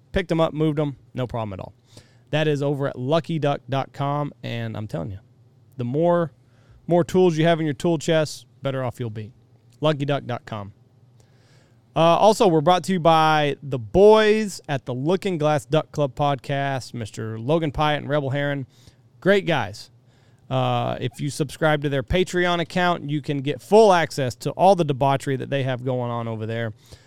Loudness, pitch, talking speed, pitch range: -22 LUFS, 140 Hz, 180 wpm, 125-160 Hz